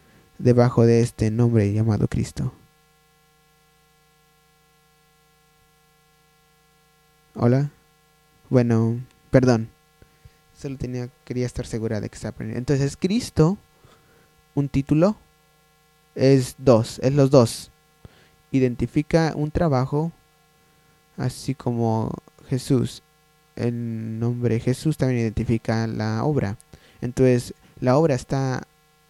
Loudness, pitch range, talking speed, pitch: -22 LUFS, 120-155 Hz, 90 wpm, 140 Hz